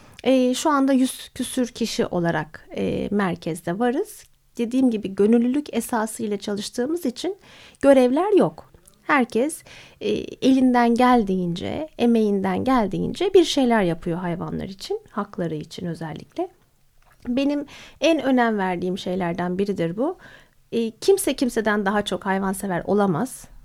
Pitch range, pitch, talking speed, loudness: 190-265 Hz, 230 Hz, 105 wpm, -22 LUFS